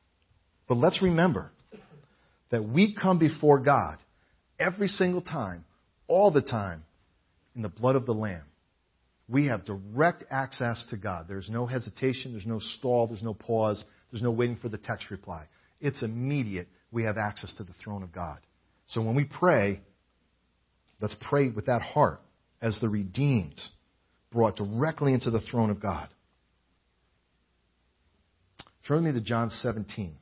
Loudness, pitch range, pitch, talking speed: -28 LUFS, 90-125 Hz, 110 Hz, 155 wpm